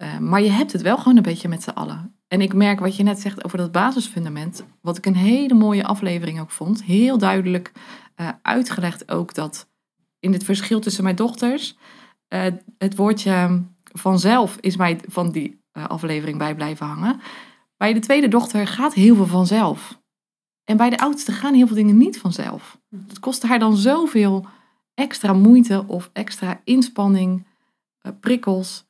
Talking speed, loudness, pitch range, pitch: 175 wpm, -19 LUFS, 185-240 Hz, 205 Hz